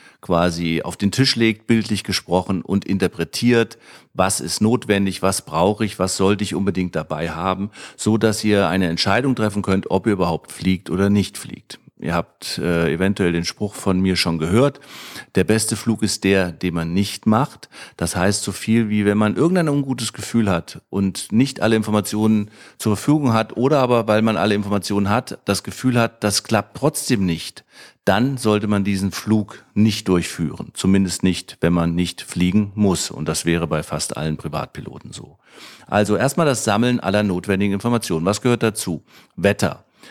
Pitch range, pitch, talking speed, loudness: 95-110 Hz, 100 Hz, 180 wpm, -20 LUFS